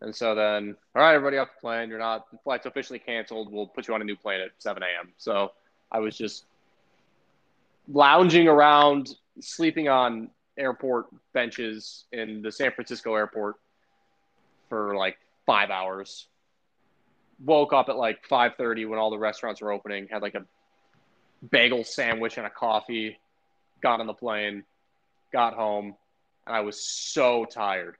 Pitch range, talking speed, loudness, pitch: 105-125 Hz, 160 wpm, -25 LUFS, 110 Hz